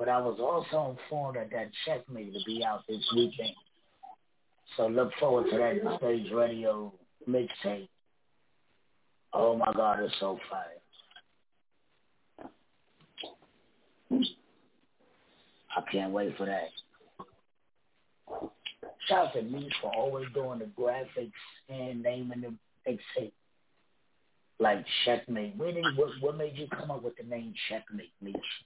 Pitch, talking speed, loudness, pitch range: 120 Hz, 125 wpm, -32 LUFS, 110-135 Hz